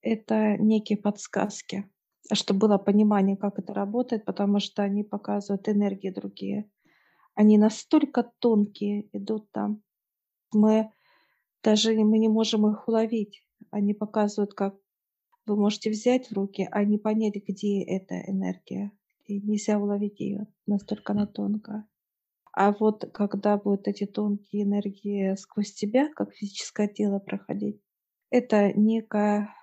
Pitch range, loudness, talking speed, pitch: 200-215 Hz, -26 LUFS, 130 wpm, 210 Hz